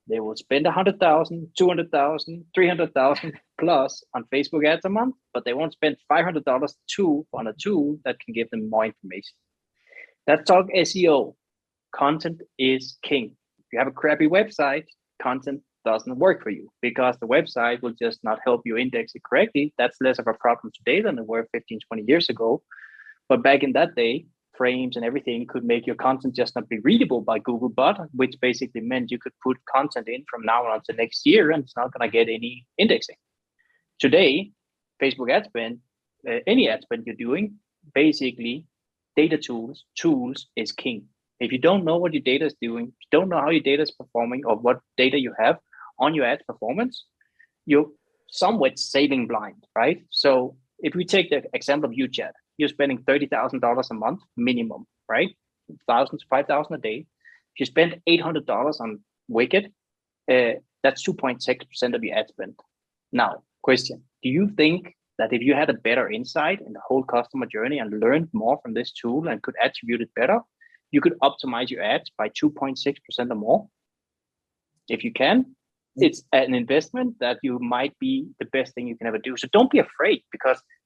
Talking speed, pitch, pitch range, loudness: 195 wpm, 140 Hz, 125-180 Hz, -23 LUFS